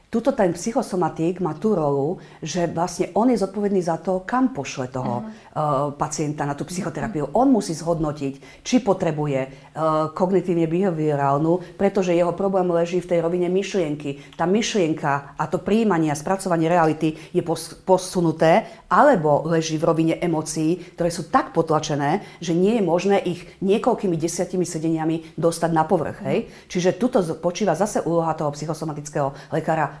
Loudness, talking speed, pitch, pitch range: -22 LUFS, 150 wpm, 170 Hz, 155-185 Hz